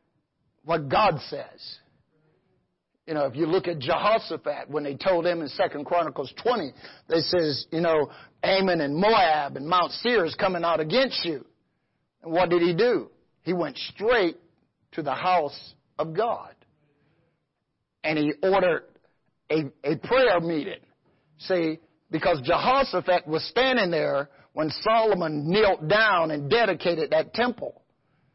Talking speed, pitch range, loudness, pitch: 140 wpm, 150-190 Hz, -24 LUFS, 165 Hz